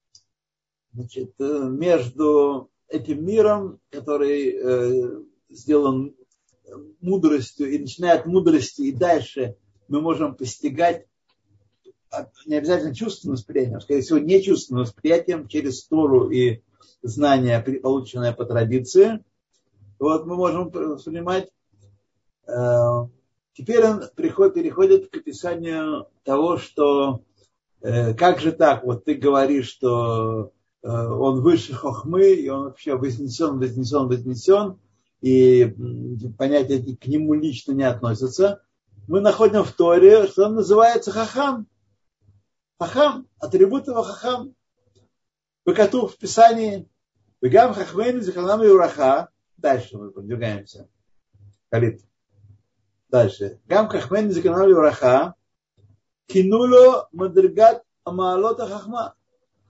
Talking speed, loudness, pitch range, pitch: 105 wpm, -19 LUFS, 120-195 Hz, 145 Hz